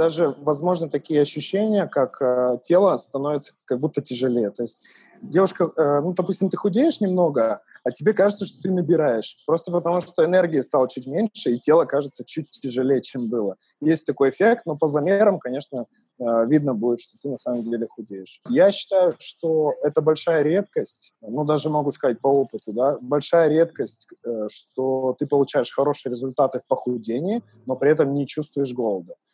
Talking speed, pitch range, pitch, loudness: 175 wpm, 130-180 Hz, 150 Hz, -22 LUFS